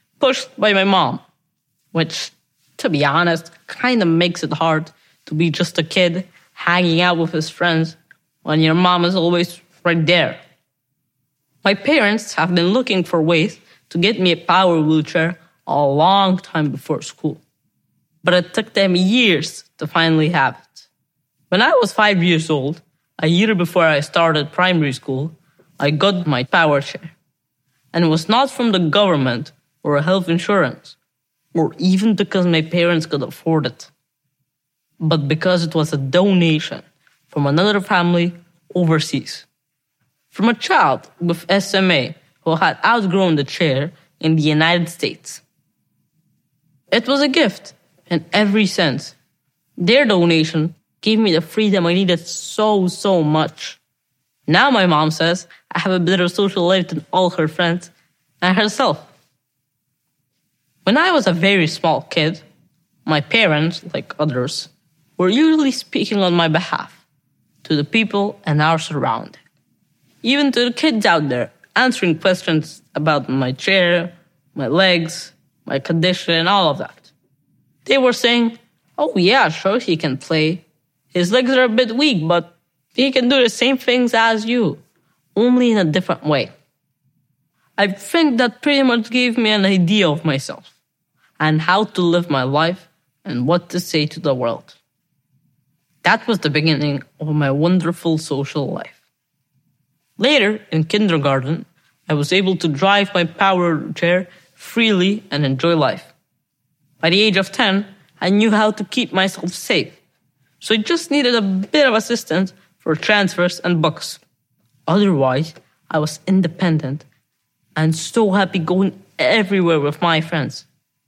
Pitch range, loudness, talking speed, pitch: 155-195 Hz, -17 LUFS, 150 wpm, 170 Hz